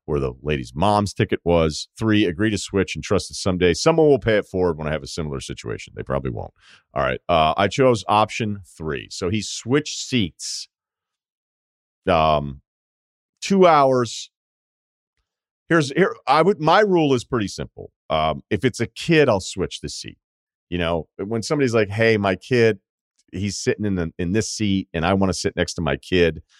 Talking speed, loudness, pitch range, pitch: 190 wpm, -21 LUFS, 80-120 Hz, 100 Hz